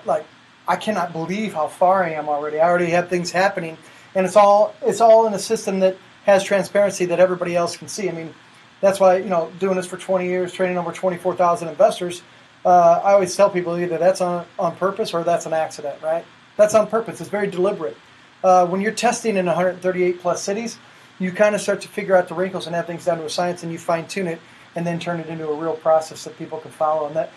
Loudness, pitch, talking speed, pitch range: -20 LUFS, 180 Hz, 245 wpm, 165-195 Hz